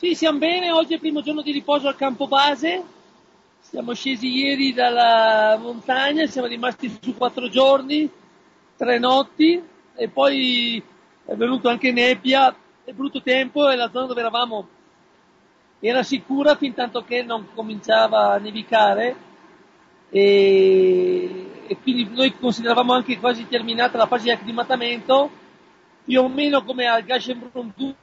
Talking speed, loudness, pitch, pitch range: 140 wpm, -19 LUFS, 255 Hz, 240-285 Hz